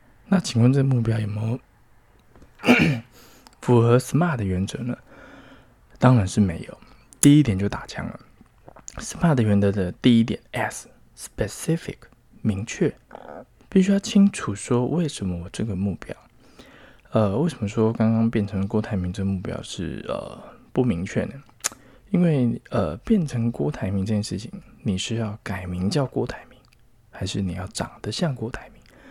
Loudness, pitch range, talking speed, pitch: -23 LUFS, 100-125 Hz, 245 characters per minute, 115 Hz